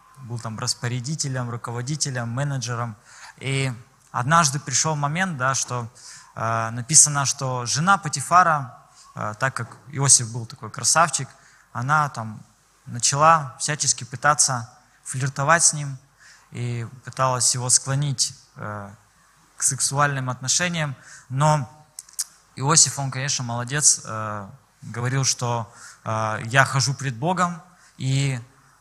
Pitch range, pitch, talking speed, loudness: 120-150 Hz, 135 Hz, 110 wpm, -21 LUFS